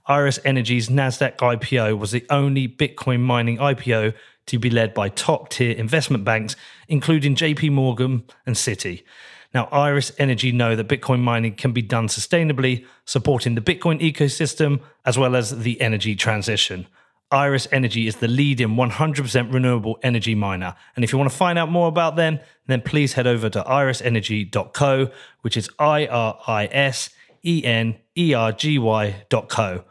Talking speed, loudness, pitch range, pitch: 160 wpm, -20 LUFS, 115-140 Hz, 125 Hz